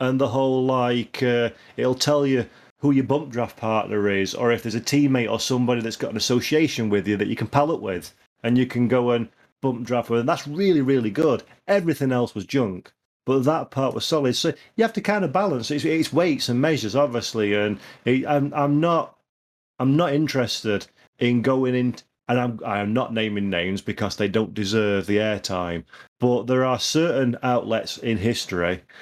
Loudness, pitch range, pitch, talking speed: -22 LUFS, 110-140 Hz, 125 Hz, 205 wpm